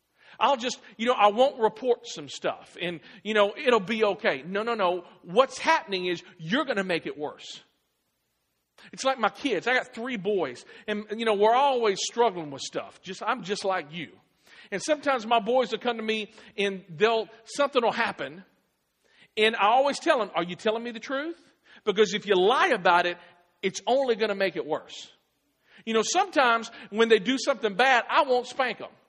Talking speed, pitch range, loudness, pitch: 200 wpm, 195-250 Hz, -26 LUFS, 220 Hz